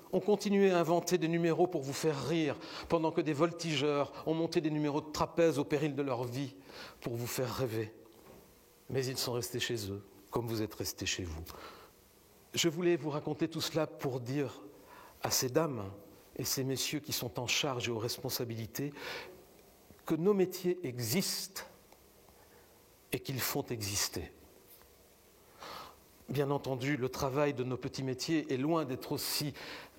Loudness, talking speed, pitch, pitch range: -34 LUFS, 165 wpm, 140 Hz, 125-165 Hz